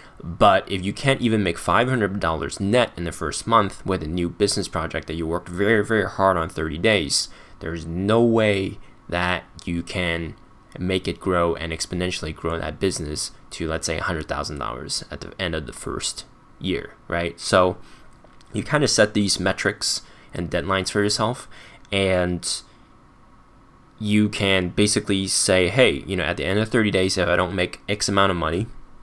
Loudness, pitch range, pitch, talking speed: -22 LUFS, 85-105 Hz, 95 Hz, 175 wpm